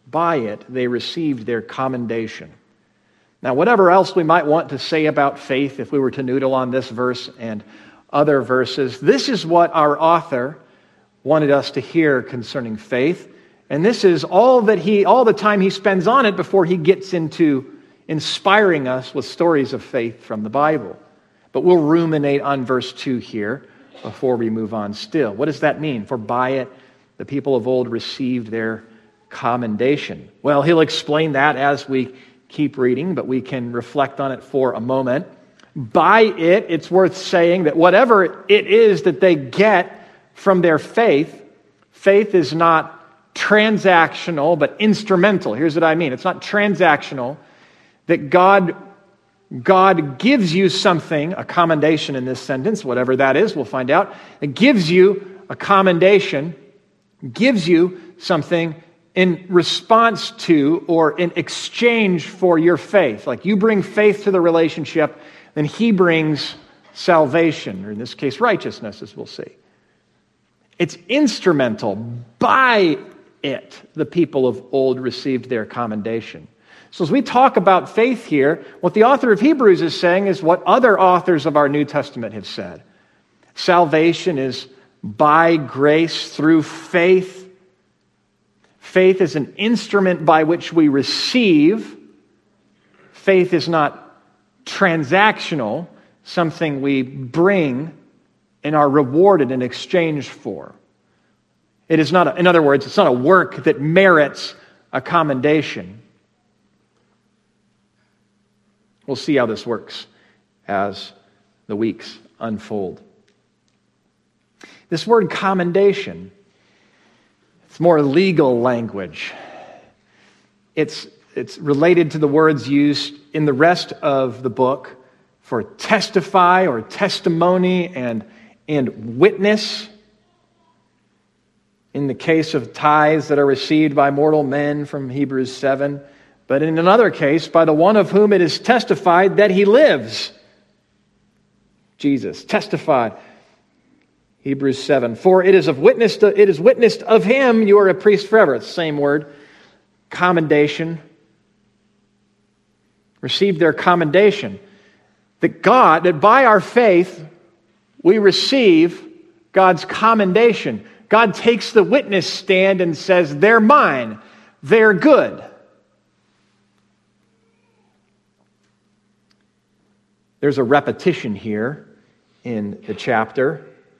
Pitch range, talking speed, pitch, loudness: 135-195 Hz, 130 wpm, 165 Hz, -16 LUFS